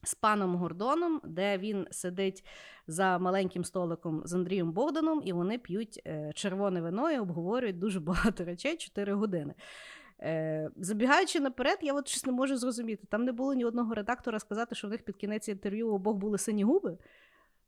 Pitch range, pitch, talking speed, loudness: 185-255 Hz, 210 Hz, 165 wpm, -32 LUFS